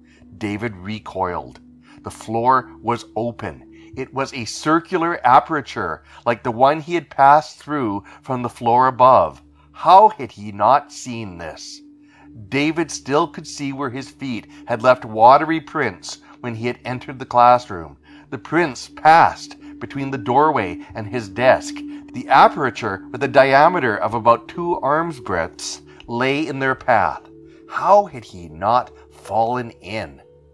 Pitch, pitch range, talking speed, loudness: 125 Hz, 110-150 Hz, 145 wpm, -18 LUFS